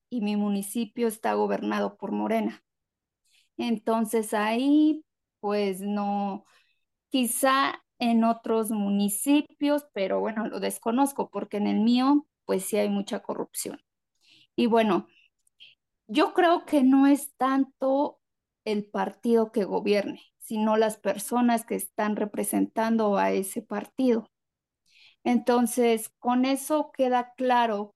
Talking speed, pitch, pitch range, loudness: 115 wpm, 225 Hz, 205-260 Hz, -26 LUFS